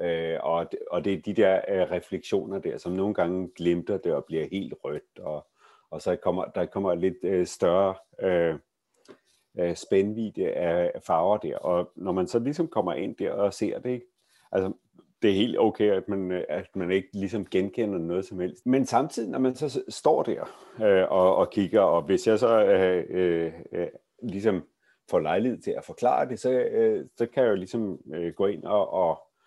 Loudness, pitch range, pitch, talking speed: -27 LUFS, 90-125 Hz, 95 Hz, 195 wpm